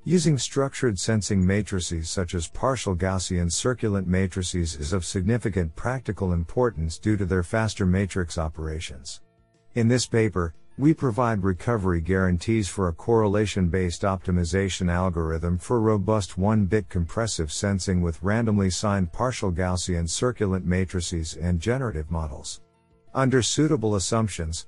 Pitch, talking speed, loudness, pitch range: 95 Hz, 125 wpm, -25 LUFS, 90-115 Hz